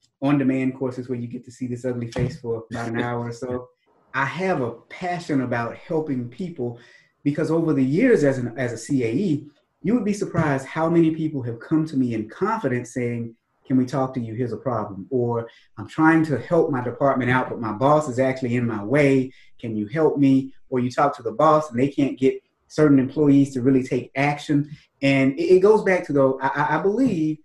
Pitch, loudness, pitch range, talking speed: 135 Hz, -22 LUFS, 125-150 Hz, 220 wpm